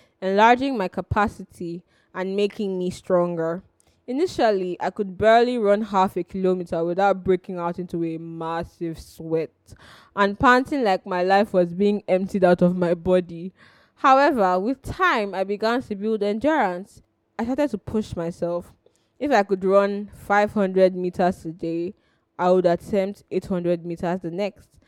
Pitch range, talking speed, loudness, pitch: 175-205 Hz, 150 wpm, -22 LUFS, 190 Hz